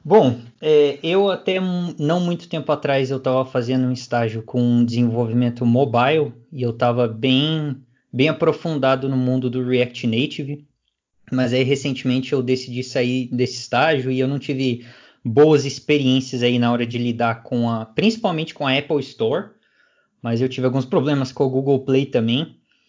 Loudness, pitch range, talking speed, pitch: -20 LUFS, 125-145 Hz, 165 wpm, 130 Hz